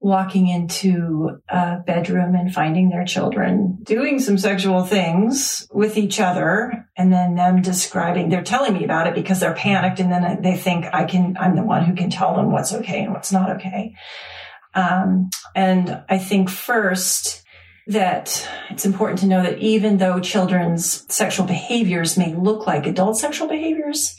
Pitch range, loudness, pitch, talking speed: 180-200 Hz, -19 LUFS, 185 Hz, 170 wpm